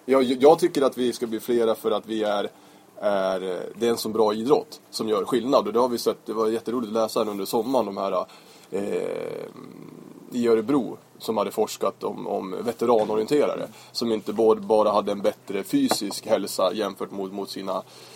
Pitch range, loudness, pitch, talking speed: 105-135 Hz, -24 LUFS, 115 Hz, 190 wpm